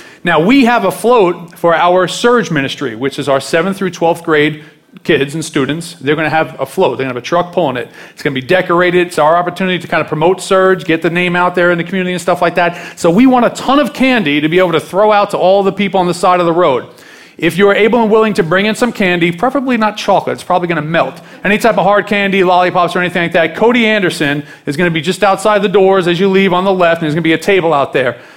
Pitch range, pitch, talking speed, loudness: 165-200 Hz, 180 Hz, 285 wpm, -12 LUFS